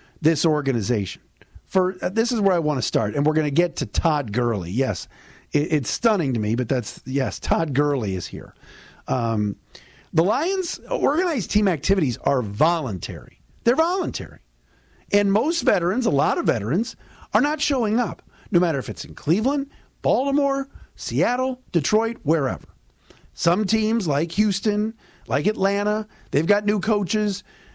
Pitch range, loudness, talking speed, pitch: 135-215 Hz, -22 LUFS, 155 wpm, 175 Hz